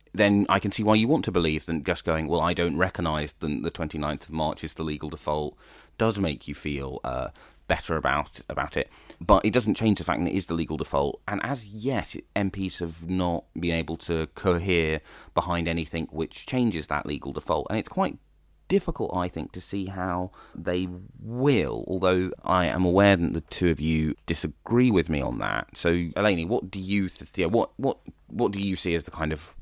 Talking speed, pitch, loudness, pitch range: 210 wpm, 85 Hz, -27 LUFS, 80-95 Hz